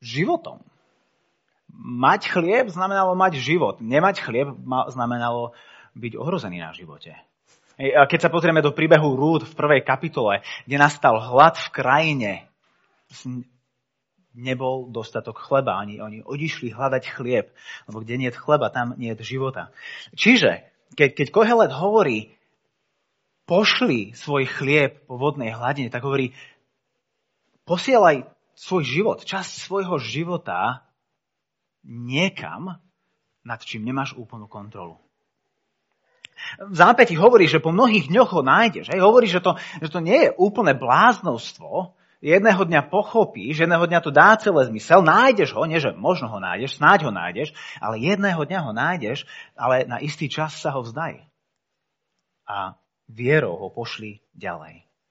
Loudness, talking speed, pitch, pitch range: -20 LUFS, 135 wpm, 145 Hz, 125-185 Hz